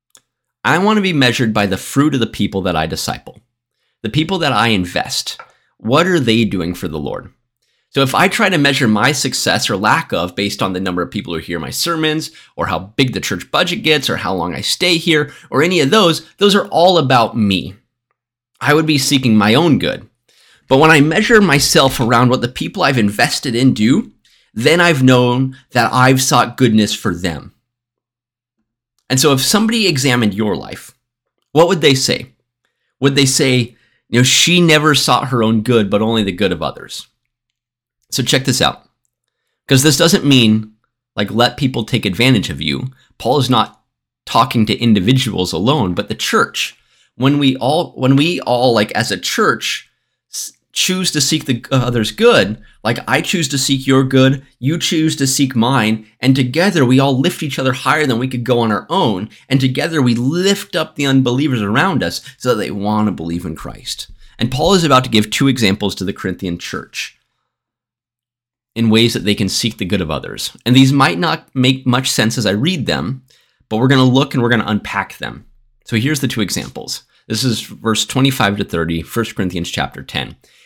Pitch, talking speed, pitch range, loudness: 125 Hz, 200 wpm, 110-140 Hz, -14 LUFS